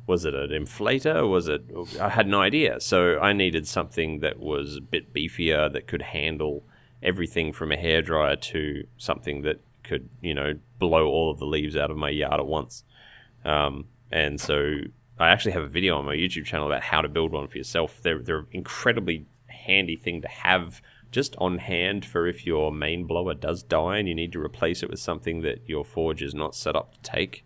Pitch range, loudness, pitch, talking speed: 75-90 Hz, -26 LUFS, 80 Hz, 210 wpm